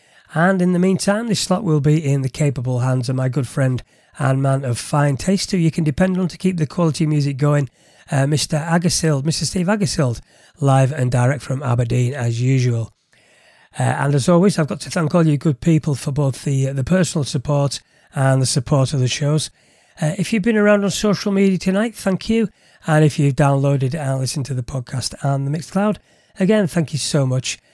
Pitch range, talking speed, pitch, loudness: 135-175 Hz, 210 wpm, 150 Hz, -18 LUFS